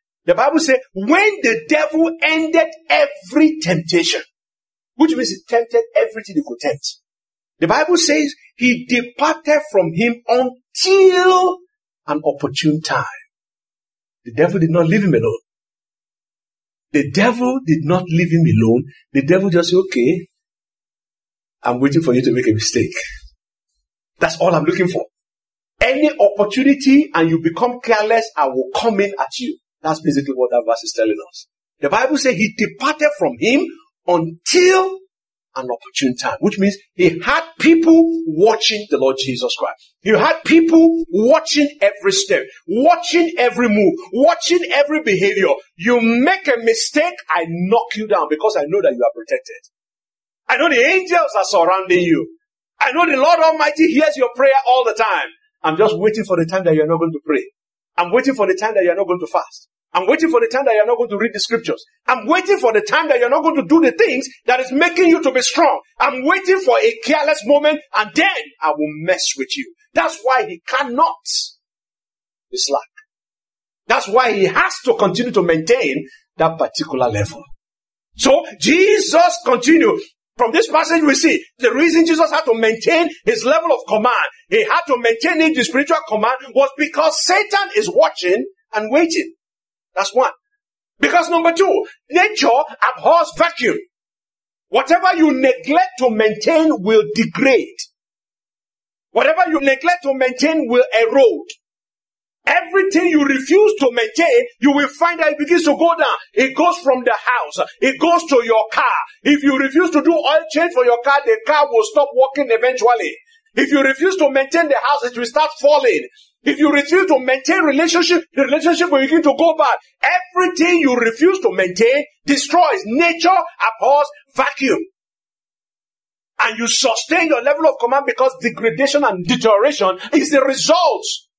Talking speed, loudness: 170 wpm, -15 LUFS